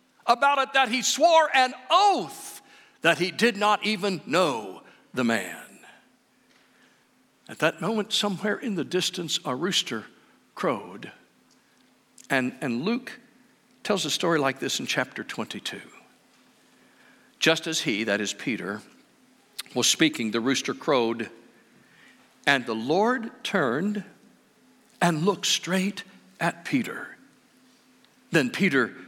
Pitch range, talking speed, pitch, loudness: 155-240 Hz, 120 wpm, 200 Hz, -25 LUFS